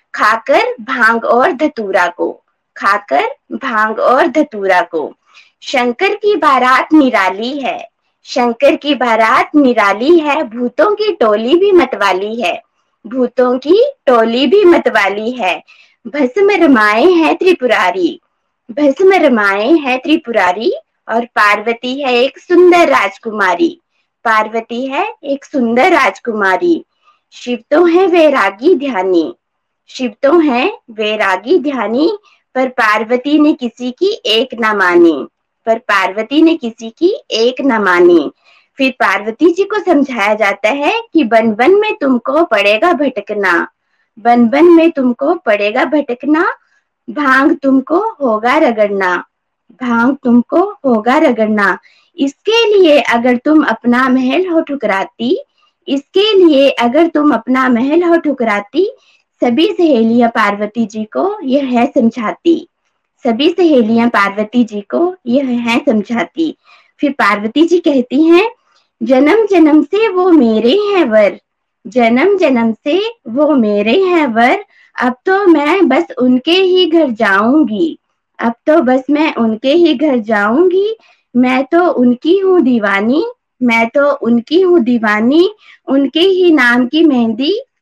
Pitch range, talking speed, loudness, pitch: 230-335 Hz, 125 wpm, -11 LUFS, 275 Hz